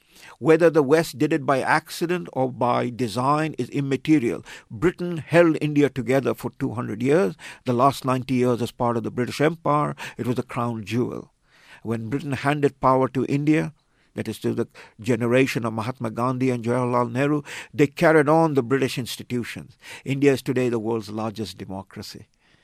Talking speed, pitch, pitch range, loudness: 170 wpm, 130 Hz, 120-145 Hz, -23 LUFS